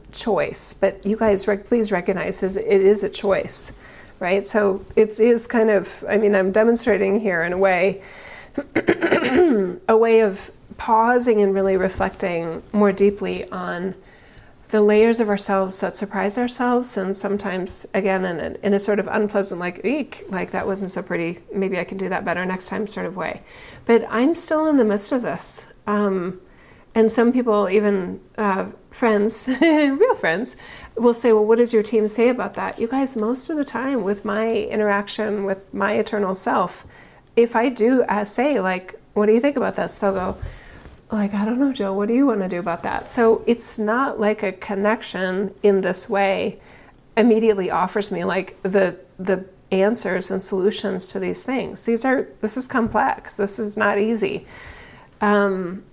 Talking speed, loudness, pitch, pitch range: 180 wpm, -20 LUFS, 205 Hz, 195-225 Hz